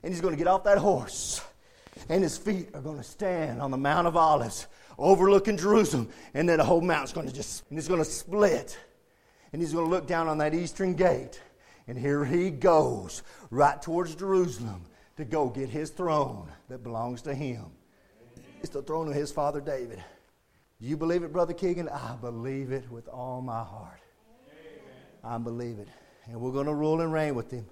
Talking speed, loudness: 200 wpm, -28 LUFS